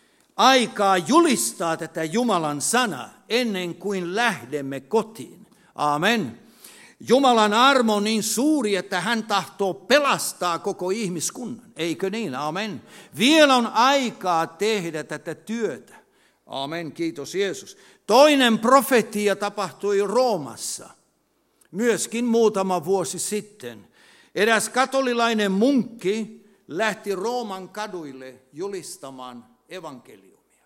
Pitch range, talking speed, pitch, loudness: 175-235 Hz, 95 wpm, 205 Hz, -22 LUFS